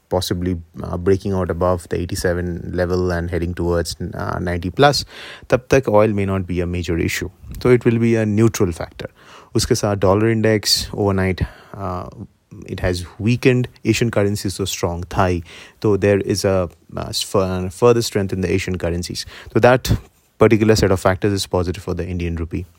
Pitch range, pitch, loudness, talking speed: 90-110 Hz, 95 Hz, -19 LUFS, 175 wpm